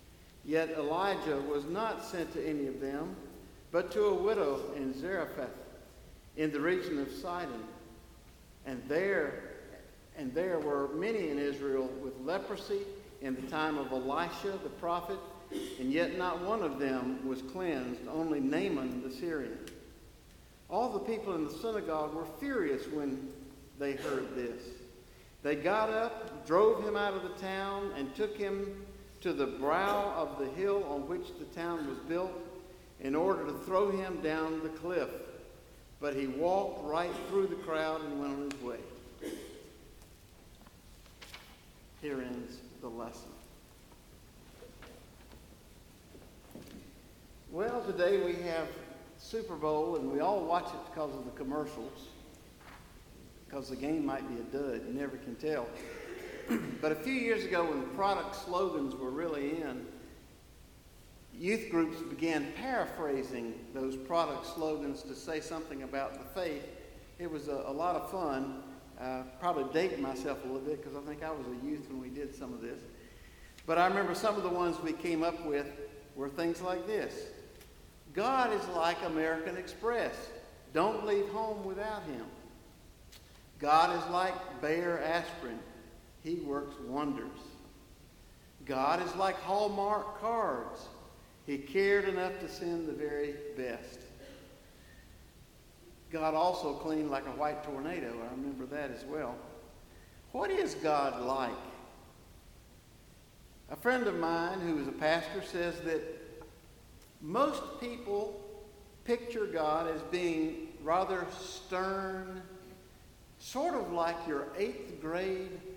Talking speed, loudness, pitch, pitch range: 140 wpm, -35 LUFS, 160 Hz, 135-190 Hz